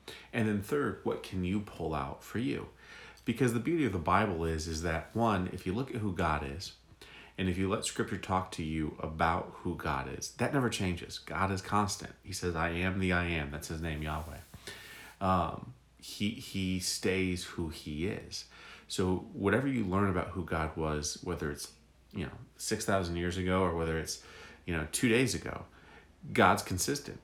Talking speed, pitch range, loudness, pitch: 195 wpm, 80-95 Hz, -33 LUFS, 90 Hz